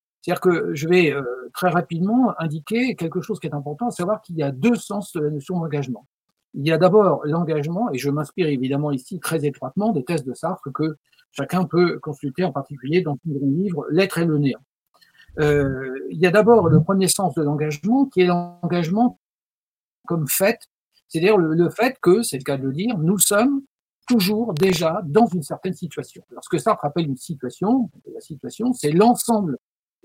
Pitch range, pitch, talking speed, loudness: 150-205 Hz, 175 Hz, 190 wpm, -21 LUFS